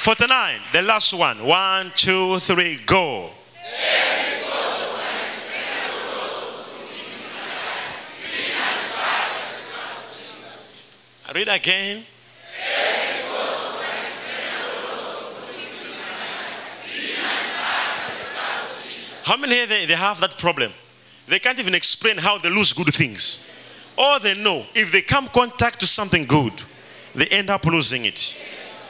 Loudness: -19 LUFS